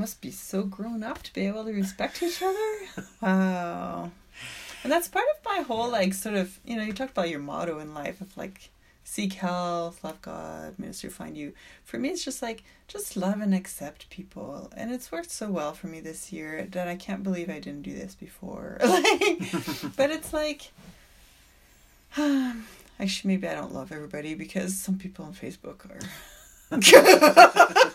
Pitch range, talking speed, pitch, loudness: 175-265 Hz, 185 wpm, 195 Hz, -24 LUFS